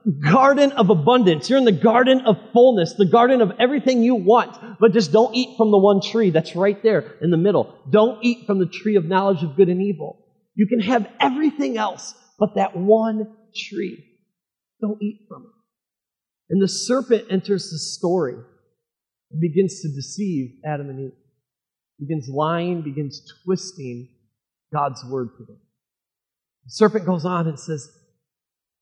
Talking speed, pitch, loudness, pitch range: 165 wpm, 195 Hz, -19 LUFS, 160-225 Hz